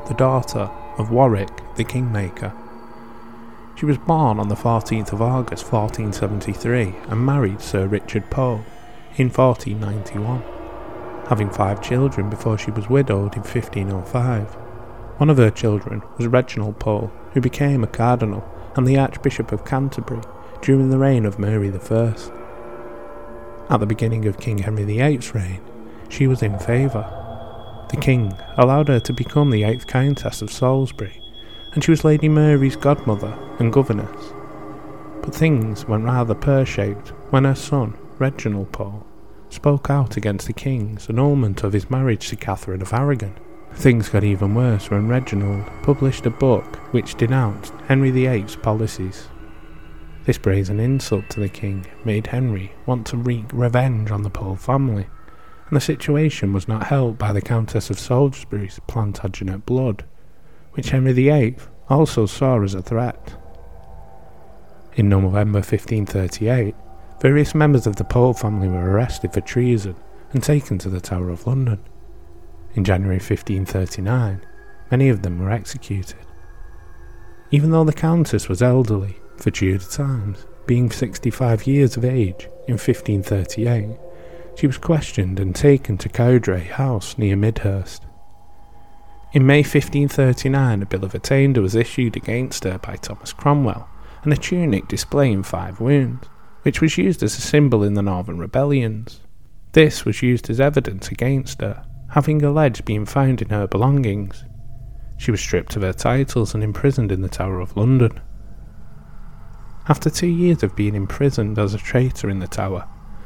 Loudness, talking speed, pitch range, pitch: -20 LUFS, 150 wpm, 100-130 Hz, 115 Hz